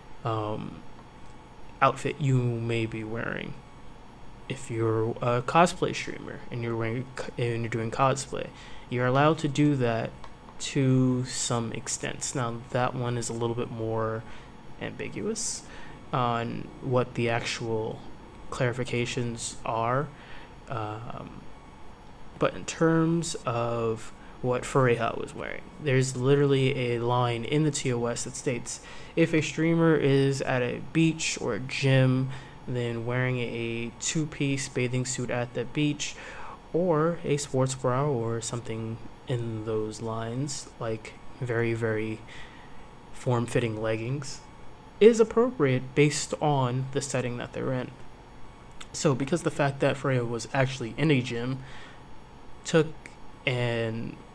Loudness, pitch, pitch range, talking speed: -28 LUFS, 125 Hz, 115-140 Hz, 125 wpm